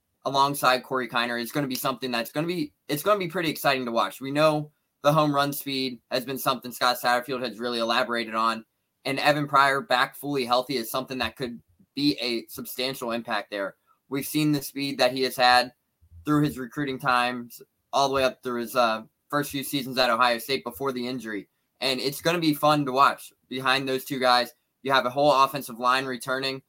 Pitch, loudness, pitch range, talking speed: 130 Hz, -25 LUFS, 125-140 Hz, 220 wpm